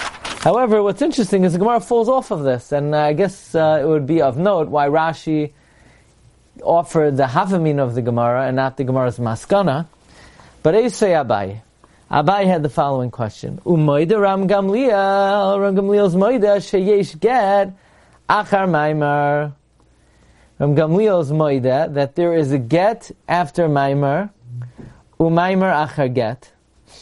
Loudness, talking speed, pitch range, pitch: -17 LUFS, 130 wpm, 140-195 Hz, 160 Hz